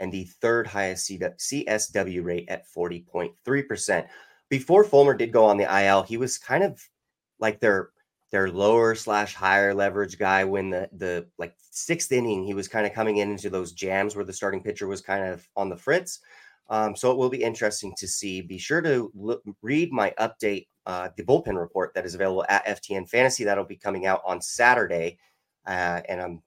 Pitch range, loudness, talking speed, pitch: 95-110 Hz, -25 LUFS, 195 wpm, 100 Hz